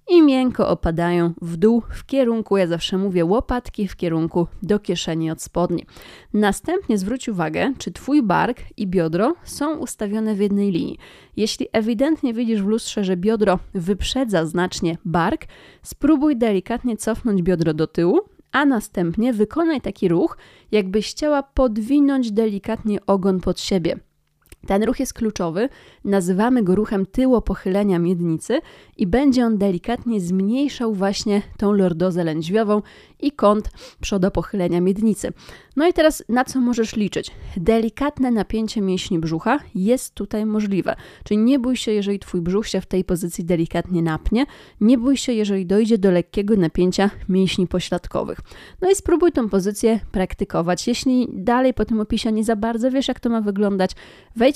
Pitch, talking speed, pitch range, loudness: 210 Hz, 150 wpm, 185-245 Hz, -20 LUFS